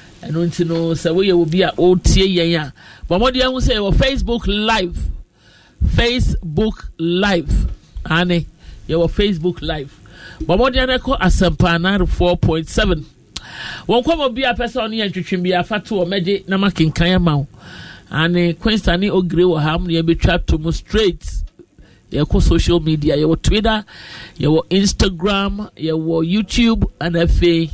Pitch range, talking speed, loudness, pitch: 165-200 Hz, 165 wpm, -17 LUFS, 175 Hz